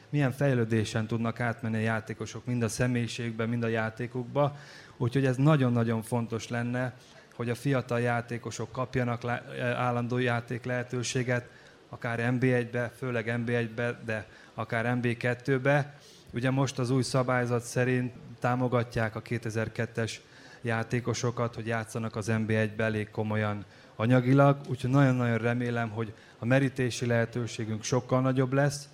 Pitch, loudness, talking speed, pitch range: 120 Hz, -29 LUFS, 125 wpm, 115-130 Hz